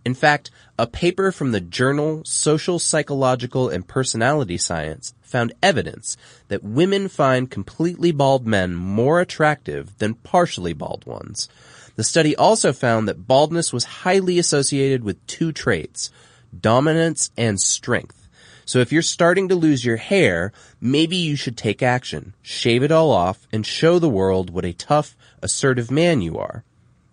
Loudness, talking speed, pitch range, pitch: -19 LUFS, 155 wpm, 115-160 Hz, 130 Hz